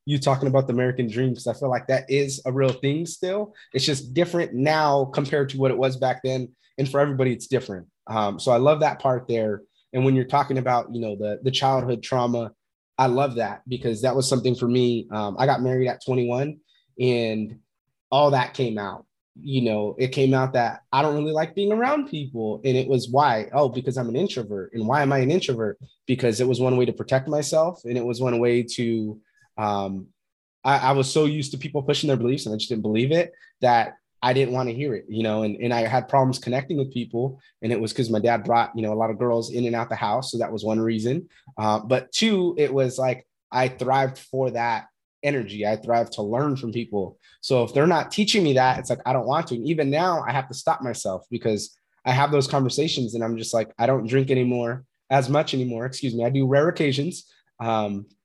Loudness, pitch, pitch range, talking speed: -23 LUFS, 130 Hz, 115-140 Hz, 235 wpm